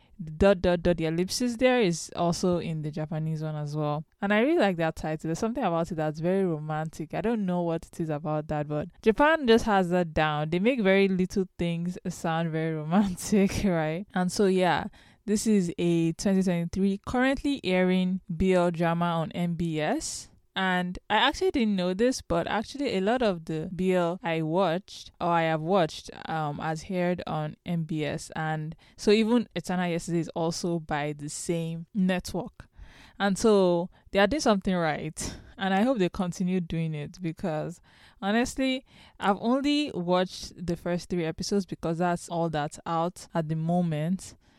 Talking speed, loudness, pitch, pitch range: 175 wpm, -27 LUFS, 180 Hz, 165-200 Hz